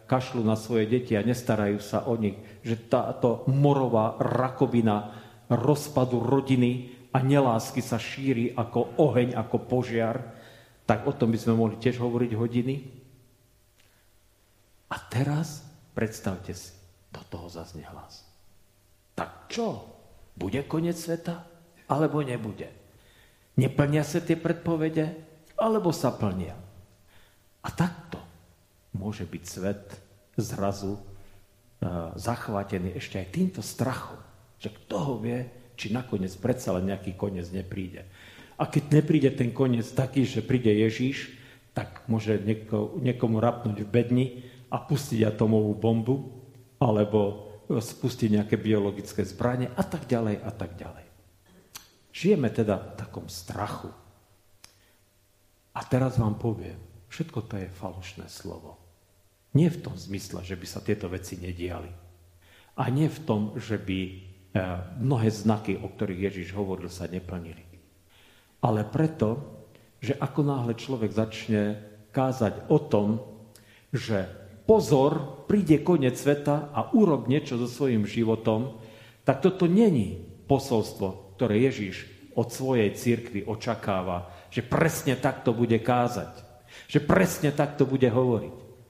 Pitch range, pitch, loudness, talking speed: 100-130 Hz, 115 Hz, -27 LUFS, 125 wpm